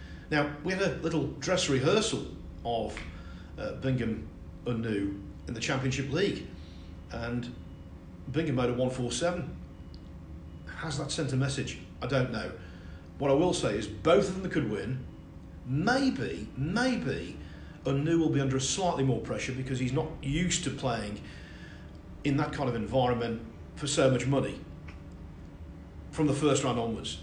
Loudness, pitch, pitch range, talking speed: -30 LUFS, 120 Hz, 85-140 Hz, 150 wpm